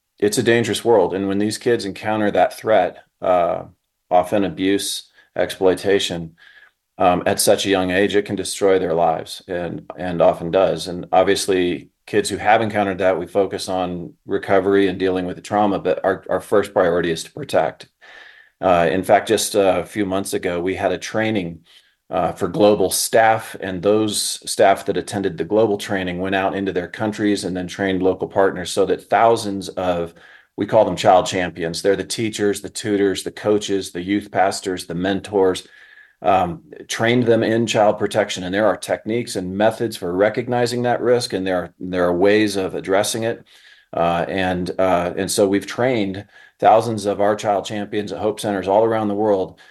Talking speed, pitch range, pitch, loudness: 185 wpm, 95-105 Hz, 100 Hz, -19 LUFS